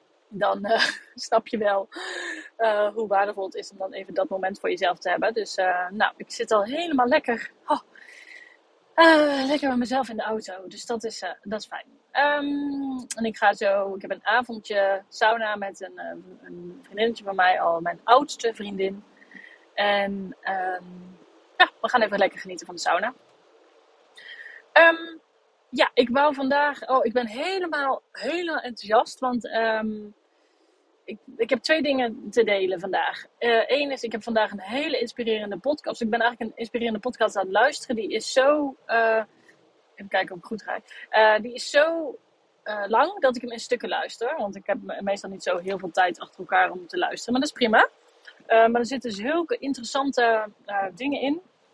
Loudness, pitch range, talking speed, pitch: -24 LUFS, 200-285 Hz, 190 wpm, 230 Hz